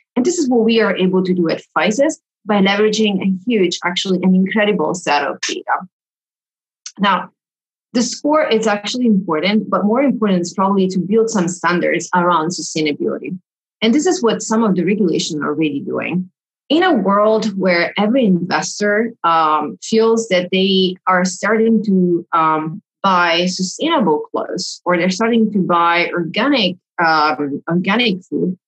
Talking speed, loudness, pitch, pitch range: 155 wpm, -16 LUFS, 190 Hz, 175-220 Hz